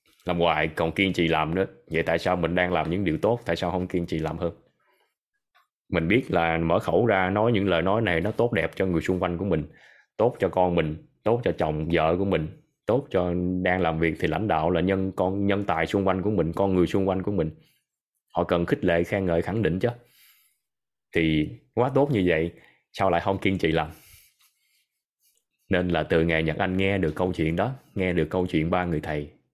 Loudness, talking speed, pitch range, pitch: -25 LUFS, 230 wpm, 80-95 Hz, 90 Hz